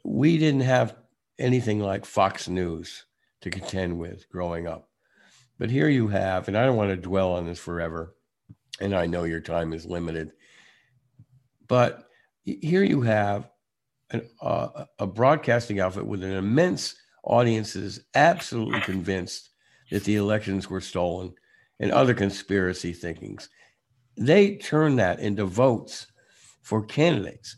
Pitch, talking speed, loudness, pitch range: 100 Hz, 135 wpm, -25 LUFS, 90-125 Hz